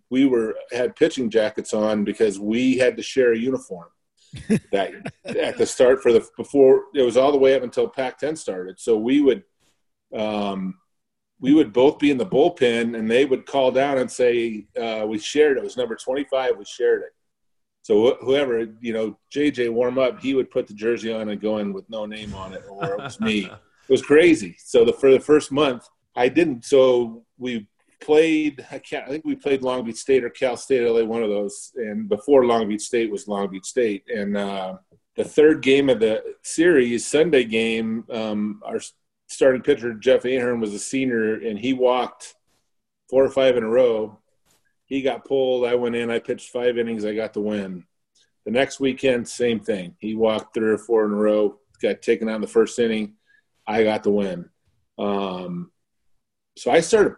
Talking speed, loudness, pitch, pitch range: 205 wpm, -21 LUFS, 120 Hz, 110-140 Hz